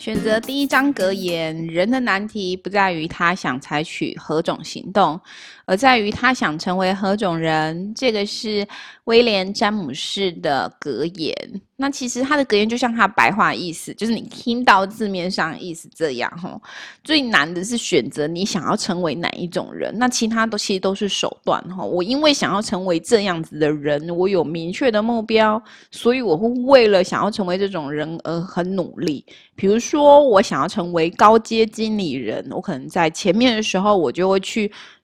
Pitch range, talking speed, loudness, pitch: 175-230 Hz, 265 characters per minute, -19 LUFS, 200 Hz